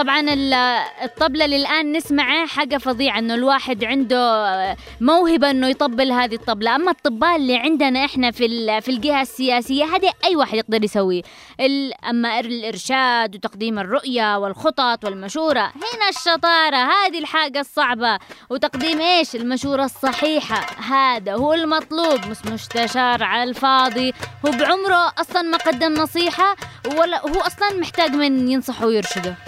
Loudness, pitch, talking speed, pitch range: -18 LUFS, 270 Hz, 130 wpm, 240-315 Hz